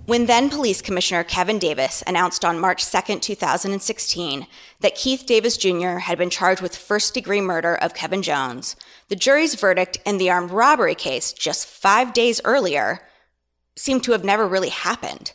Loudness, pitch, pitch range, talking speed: -20 LUFS, 195 Hz, 180-235 Hz, 165 wpm